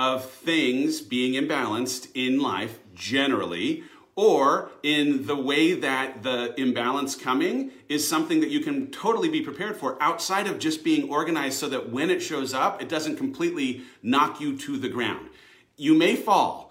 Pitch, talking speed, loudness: 155 Hz, 165 wpm, -25 LUFS